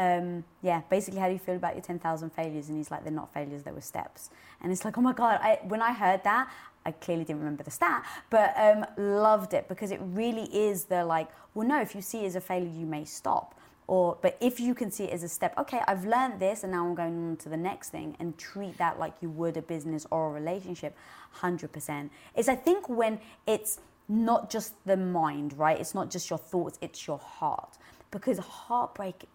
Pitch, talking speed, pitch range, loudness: 185 Hz, 235 wpm, 165-215 Hz, -30 LUFS